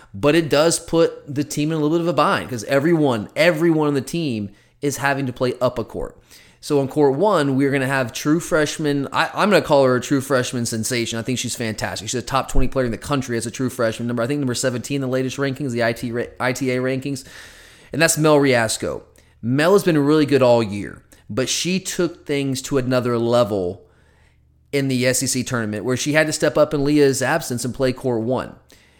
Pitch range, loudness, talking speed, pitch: 120-145 Hz, -20 LUFS, 230 wpm, 130 Hz